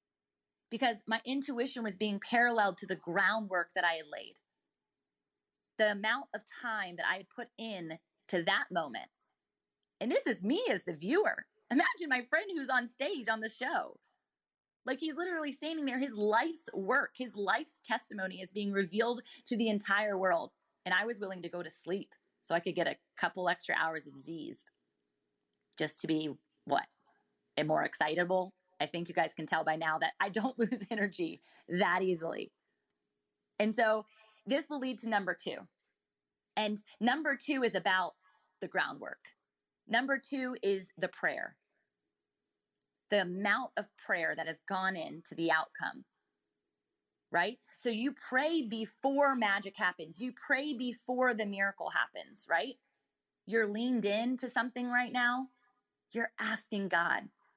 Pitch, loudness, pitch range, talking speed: 215 Hz, -34 LUFS, 180-245 Hz, 160 wpm